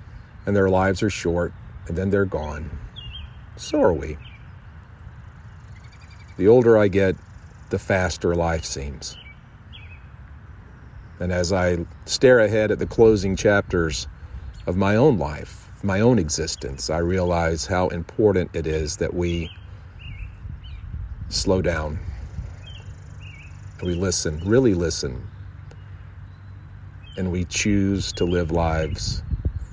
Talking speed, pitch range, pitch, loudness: 115 wpm, 85-100 Hz, 95 Hz, -22 LUFS